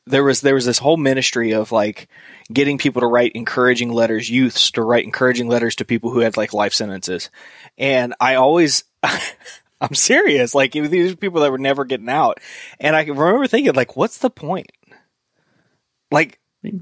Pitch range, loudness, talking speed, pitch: 115-150 Hz, -17 LUFS, 180 wpm, 130 Hz